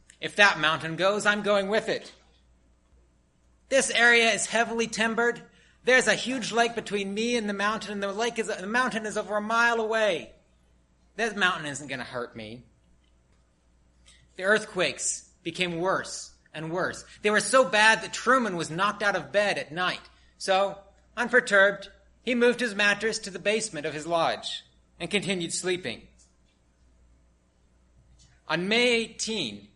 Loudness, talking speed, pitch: -25 LUFS, 155 wpm, 195 Hz